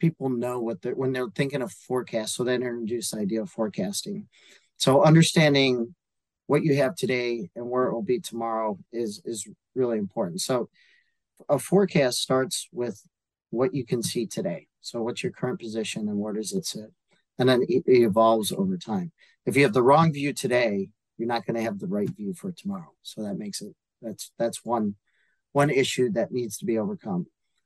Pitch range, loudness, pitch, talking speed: 115-190 Hz, -26 LUFS, 130 Hz, 195 wpm